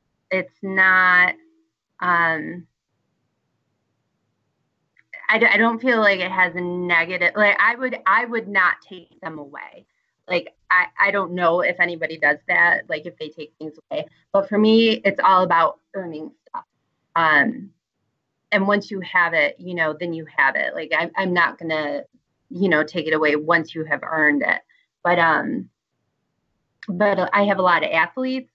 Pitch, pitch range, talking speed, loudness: 180 Hz, 160-205 Hz, 170 wpm, -19 LUFS